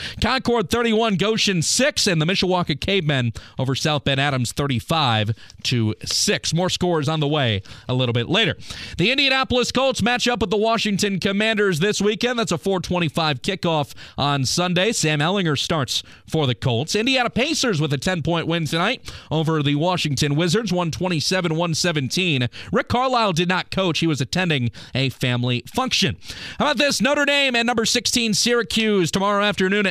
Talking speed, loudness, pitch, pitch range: 165 wpm, -20 LUFS, 175 Hz, 145-215 Hz